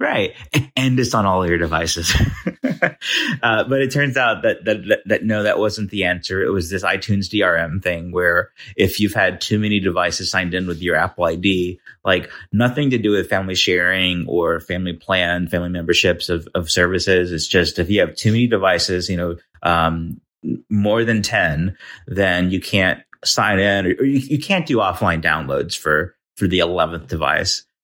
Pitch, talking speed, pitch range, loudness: 95 Hz, 190 wpm, 90-105 Hz, -18 LUFS